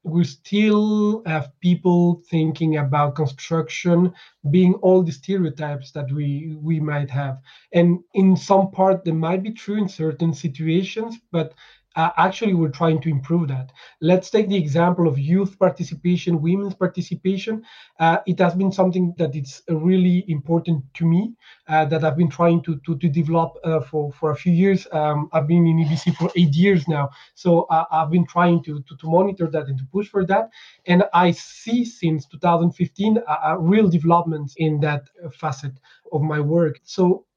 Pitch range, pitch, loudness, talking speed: 155-185 Hz, 170 Hz, -20 LUFS, 175 wpm